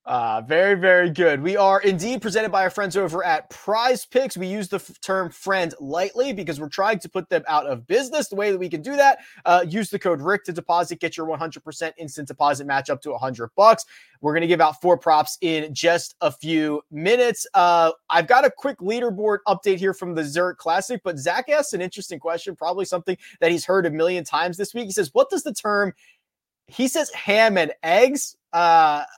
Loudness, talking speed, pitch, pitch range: -21 LUFS, 220 wpm, 185 Hz, 165-210 Hz